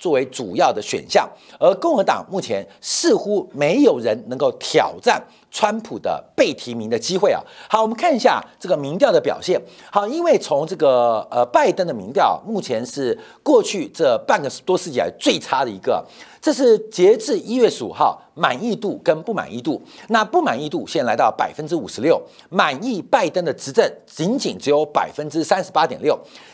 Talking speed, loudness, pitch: 285 characters per minute, -19 LUFS, 235 Hz